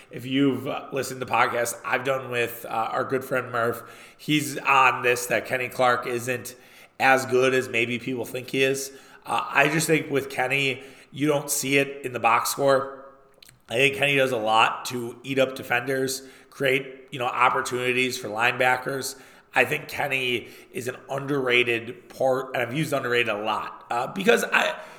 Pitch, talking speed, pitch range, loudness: 130 Hz, 180 wpm, 125-135 Hz, -24 LUFS